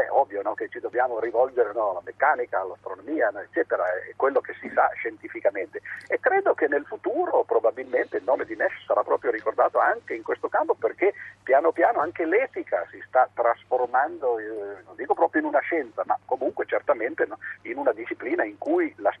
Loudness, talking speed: -25 LUFS, 180 wpm